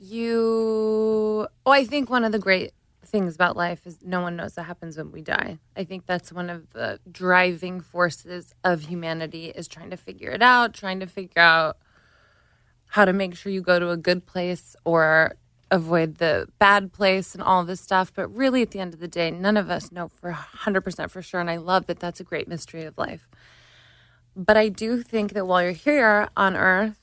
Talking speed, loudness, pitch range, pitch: 215 wpm, -22 LUFS, 175-205 Hz, 185 Hz